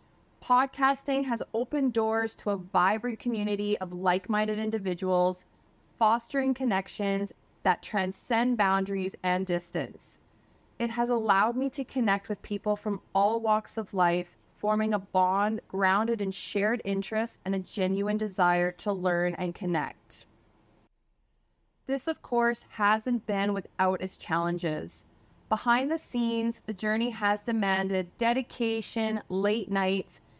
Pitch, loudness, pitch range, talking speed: 205 Hz, -29 LUFS, 185-230 Hz, 130 wpm